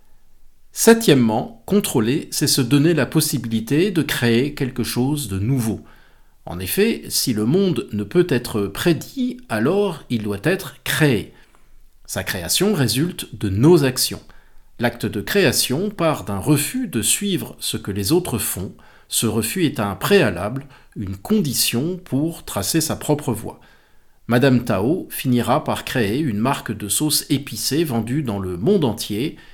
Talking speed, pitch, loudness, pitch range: 150 wpm, 130 Hz, -20 LUFS, 110-160 Hz